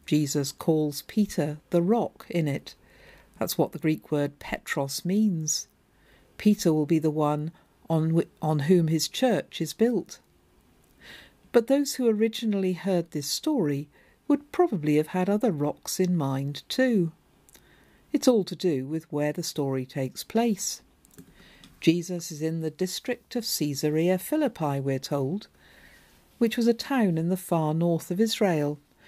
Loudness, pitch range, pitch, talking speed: -27 LUFS, 150-215 Hz, 170 Hz, 150 wpm